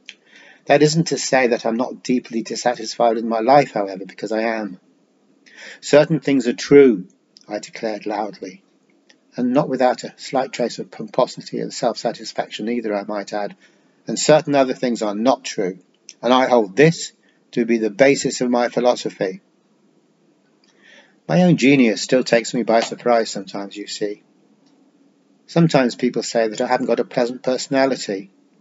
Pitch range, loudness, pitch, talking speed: 110-140 Hz, -19 LUFS, 120 Hz, 160 wpm